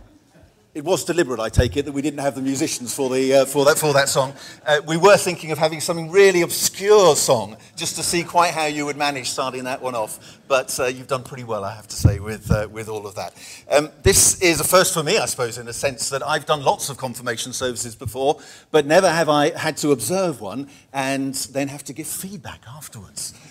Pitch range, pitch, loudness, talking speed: 125-160 Hz, 145 Hz, -19 LUFS, 235 wpm